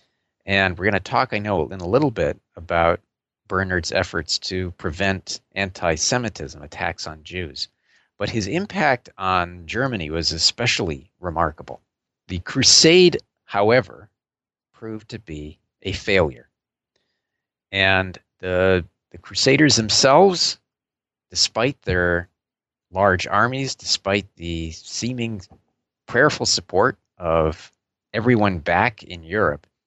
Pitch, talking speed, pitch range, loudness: 95 Hz, 115 wpm, 85-110 Hz, -20 LUFS